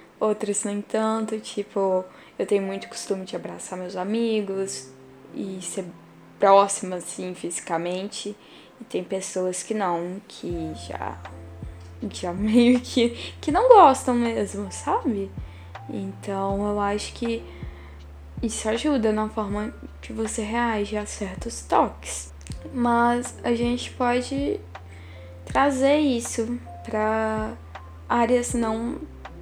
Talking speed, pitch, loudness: 115 wpm, 200 Hz, -24 LUFS